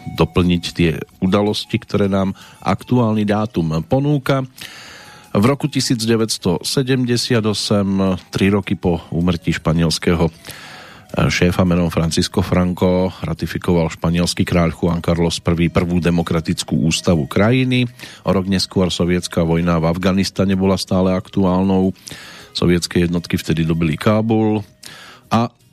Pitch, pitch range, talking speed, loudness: 95 Hz, 85-105 Hz, 105 wpm, -17 LUFS